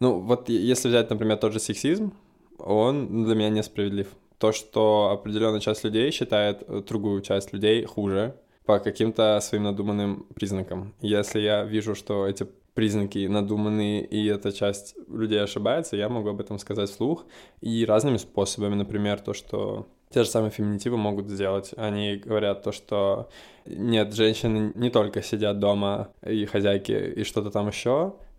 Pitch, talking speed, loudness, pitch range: 105 Hz, 155 wpm, -26 LUFS, 100-110 Hz